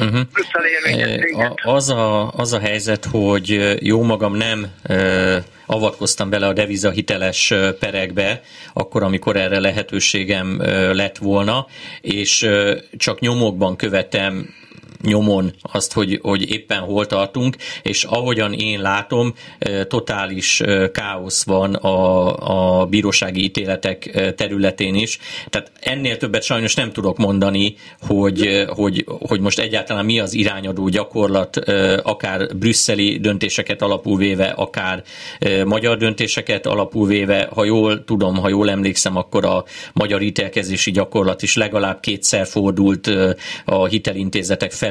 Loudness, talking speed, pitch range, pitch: -17 LUFS, 120 wpm, 95-110 Hz, 100 Hz